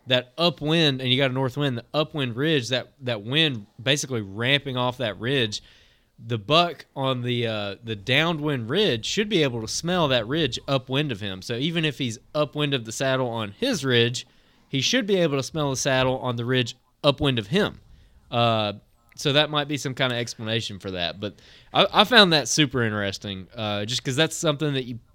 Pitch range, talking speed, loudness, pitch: 115-150 Hz, 210 wpm, -23 LUFS, 130 Hz